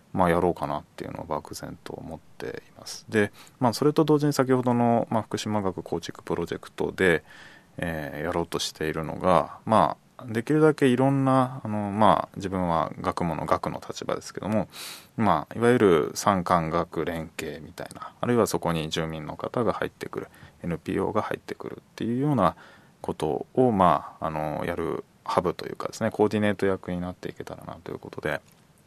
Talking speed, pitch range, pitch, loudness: 380 characters per minute, 85-125 Hz, 105 Hz, -26 LUFS